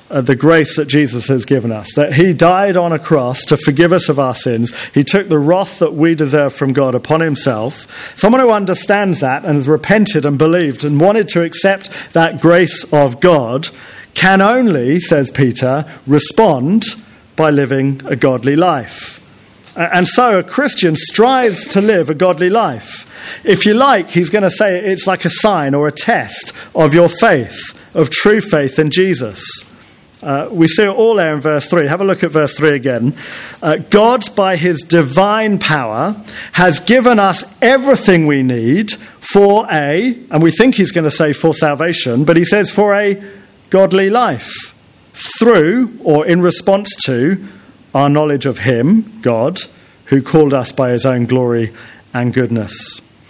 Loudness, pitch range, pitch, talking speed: -12 LUFS, 140-195 Hz, 165 Hz, 175 wpm